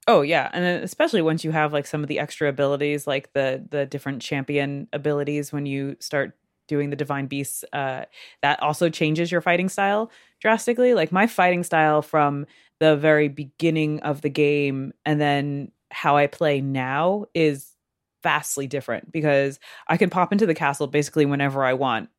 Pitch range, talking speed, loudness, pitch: 140-160 Hz, 175 wpm, -22 LUFS, 150 Hz